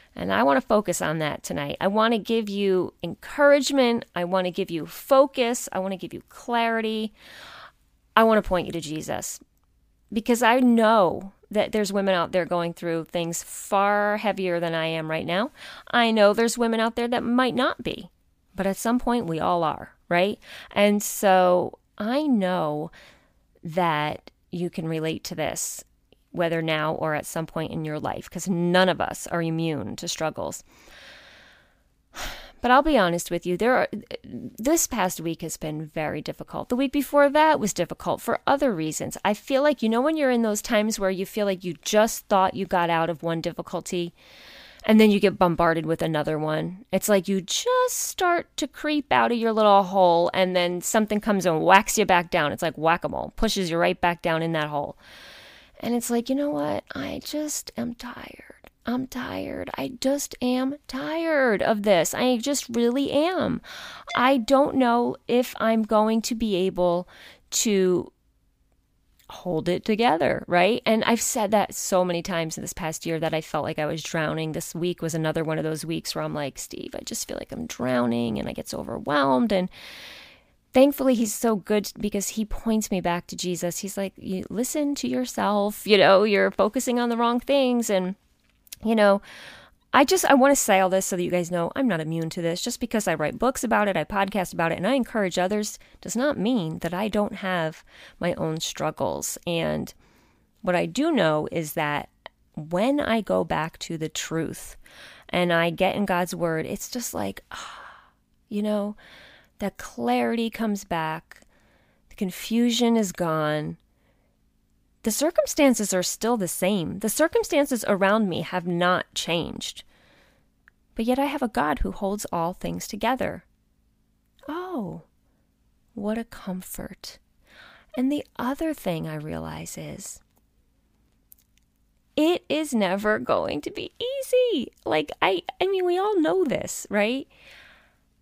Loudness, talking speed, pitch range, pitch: -24 LUFS, 180 wpm, 175-245 Hz, 205 Hz